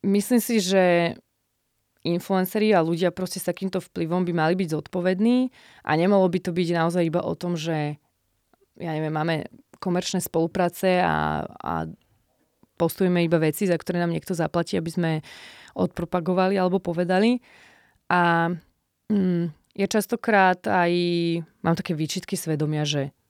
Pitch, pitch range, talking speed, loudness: 175 Hz, 165-185 Hz, 140 wpm, -24 LUFS